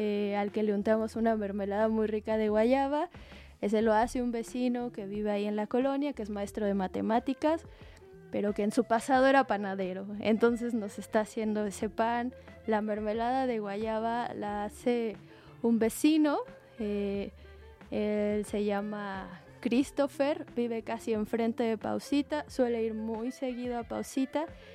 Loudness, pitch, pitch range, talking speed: -31 LUFS, 220 Hz, 210-245 Hz, 155 wpm